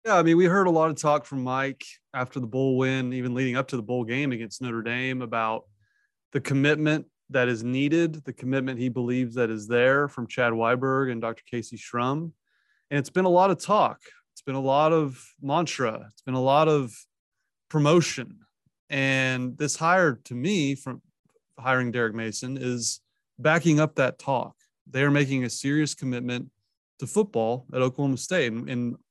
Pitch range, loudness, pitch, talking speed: 125-150 Hz, -25 LUFS, 130 Hz, 190 wpm